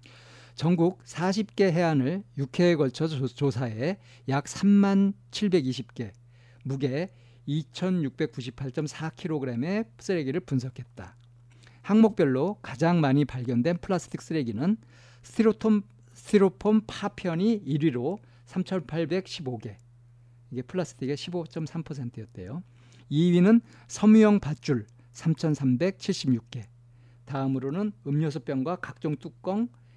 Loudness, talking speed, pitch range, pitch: -27 LUFS, 190 characters per minute, 120-180 Hz, 145 Hz